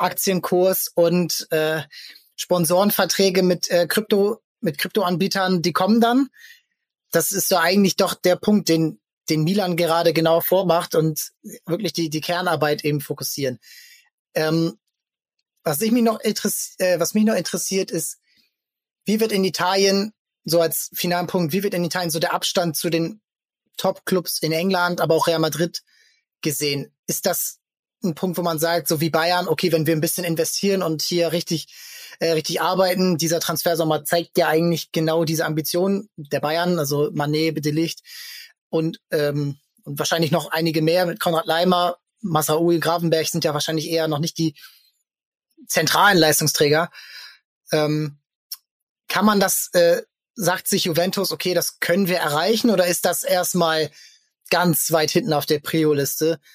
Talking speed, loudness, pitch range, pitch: 160 wpm, -20 LUFS, 160-190 Hz, 175 Hz